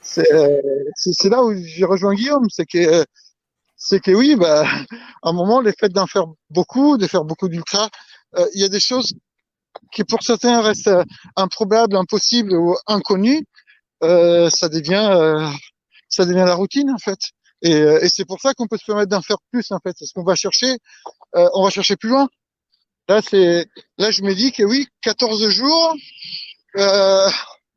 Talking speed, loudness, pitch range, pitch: 180 wpm, -16 LUFS, 180-235 Hz, 200 Hz